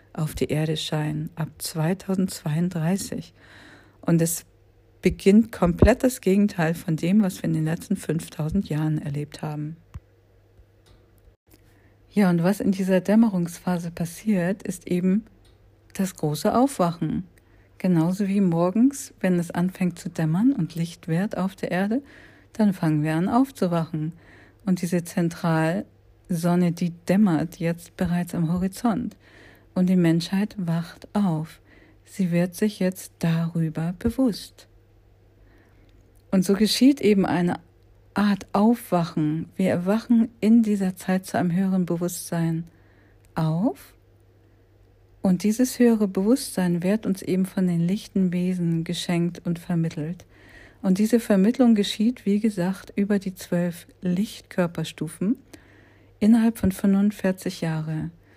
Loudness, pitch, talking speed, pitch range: -24 LUFS, 175 Hz, 120 wpm, 155-195 Hz